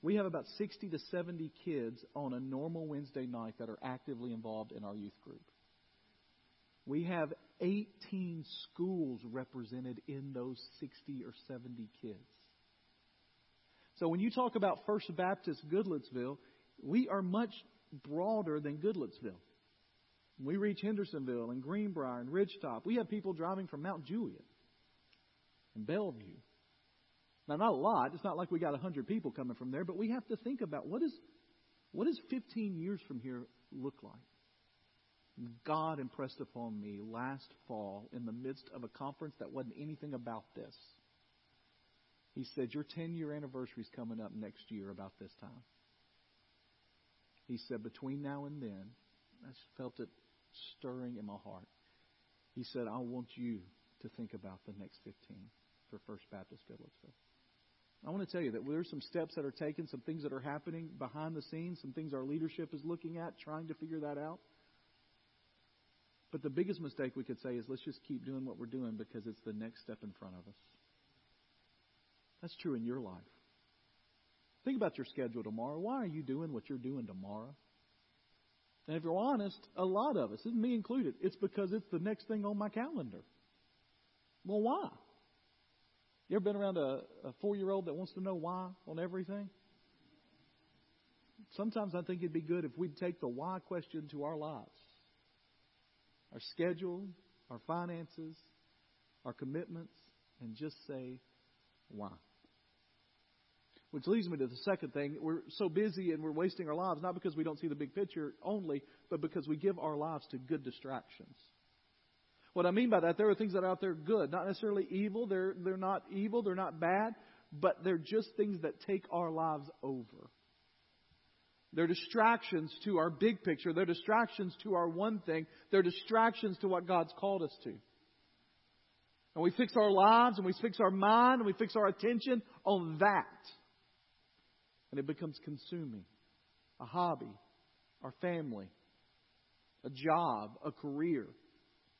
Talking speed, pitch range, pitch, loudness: 170 wpm, 120-190 Hz, 155 Hz, -38 LUFS